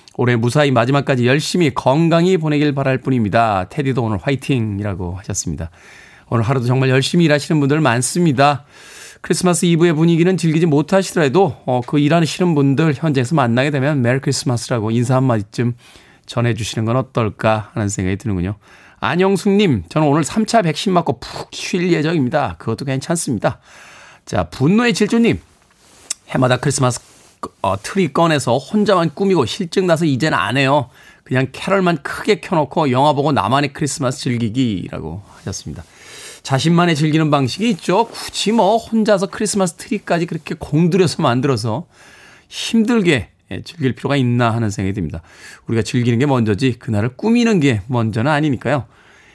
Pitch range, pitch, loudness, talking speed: 120-170 Hz, 140 Hz, -17 LUFS, 375 characters per minute